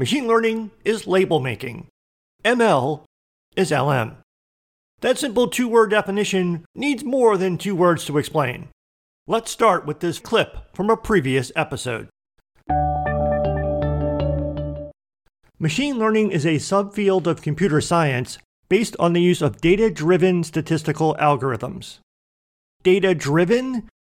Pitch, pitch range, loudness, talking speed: 165 Hz, 130-205 Hz, -20 LUFS, 120 wpm